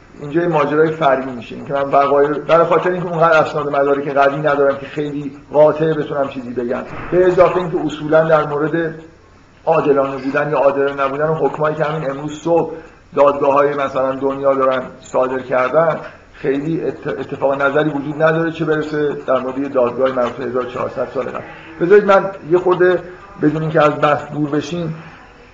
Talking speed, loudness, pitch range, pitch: 170 wpm, -16 LUFS, 140-160 Hz, 150 Hz